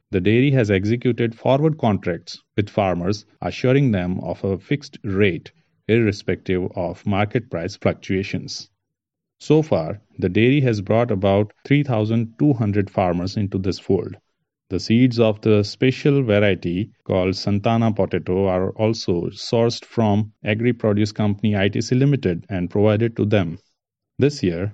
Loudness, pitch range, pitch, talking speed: -20 LUFS, 95-120 Hz, 105 Hz, 135 wpm